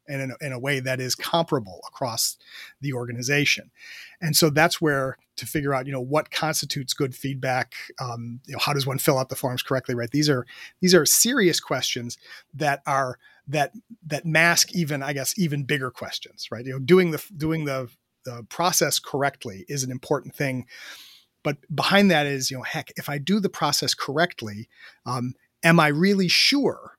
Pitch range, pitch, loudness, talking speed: 130-160 Hz, 140 Hz, -23 LUFS, 190 wpm